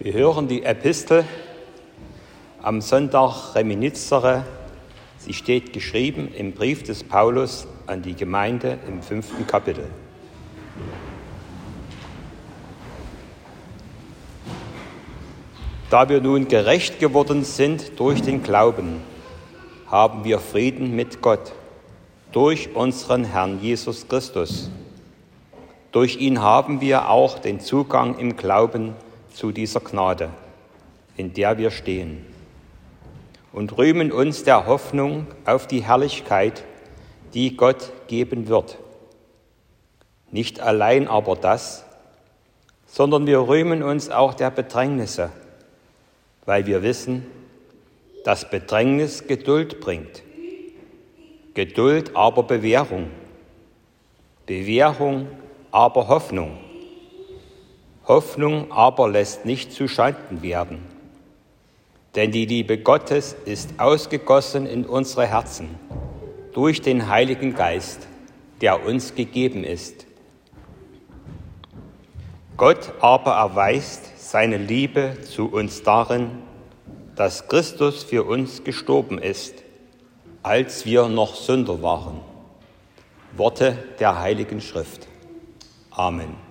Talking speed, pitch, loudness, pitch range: 95 wpm, 125 Hz, -20 LUFS, 105-140 Hz